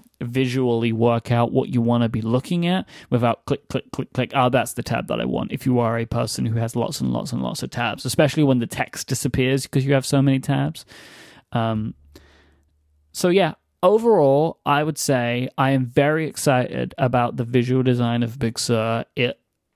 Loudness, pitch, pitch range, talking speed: -21 LUFS, 125 Hz, 115-140 Hz, 200 wpm